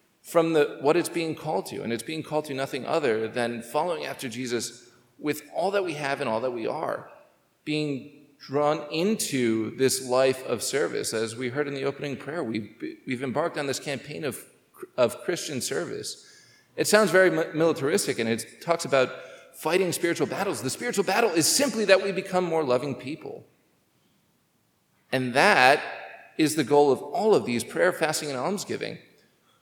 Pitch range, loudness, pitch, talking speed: 130-170 Hz, -26 LUFS, 150 Hz, 175 wpm